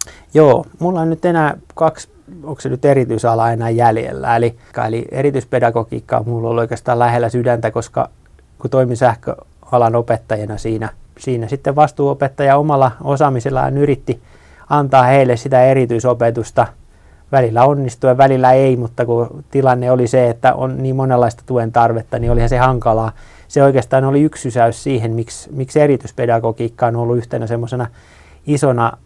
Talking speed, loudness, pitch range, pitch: 145 wpm, -15 LUFS, 115-135 Hz, 125 Hz